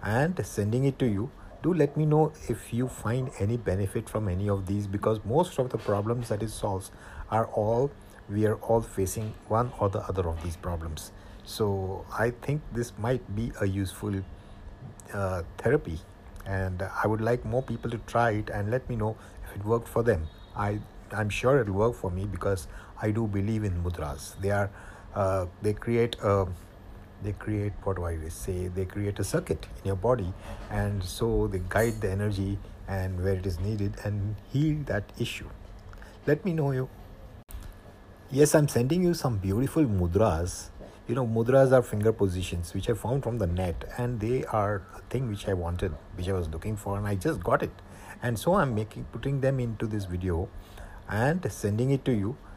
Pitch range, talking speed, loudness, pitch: 95-115 Hz, 195 wpm, -29 LUFS, 105 Hz